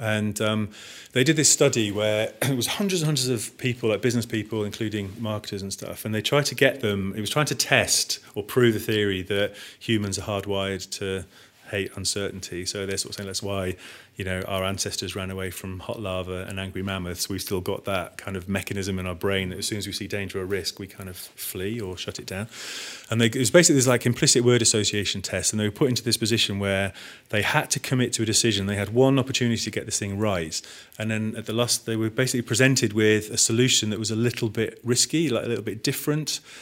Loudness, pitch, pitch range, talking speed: -24 LUFS, 110 Hz, 100-120 Hz, 240 wpm